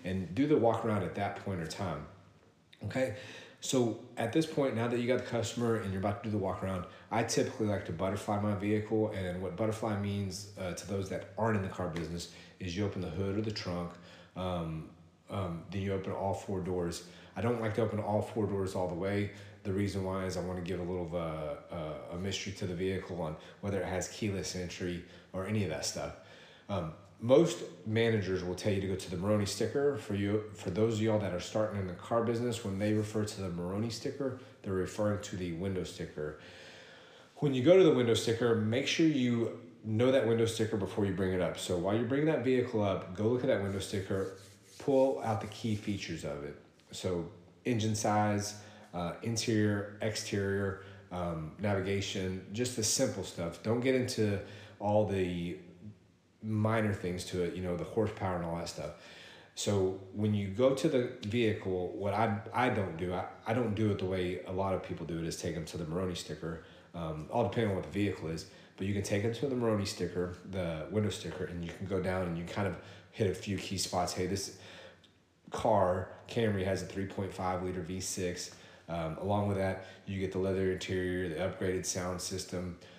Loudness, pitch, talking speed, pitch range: -34 LUFS, 95 Hz, 215 wpm, 90-110 Hz